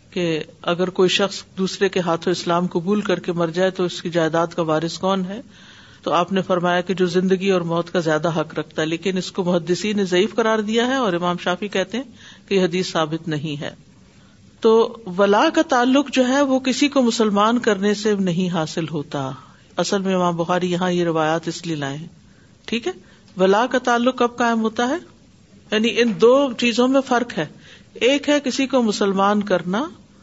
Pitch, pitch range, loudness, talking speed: 190 Hz, 175-230 Hz, -20 LUFS, 200 wpm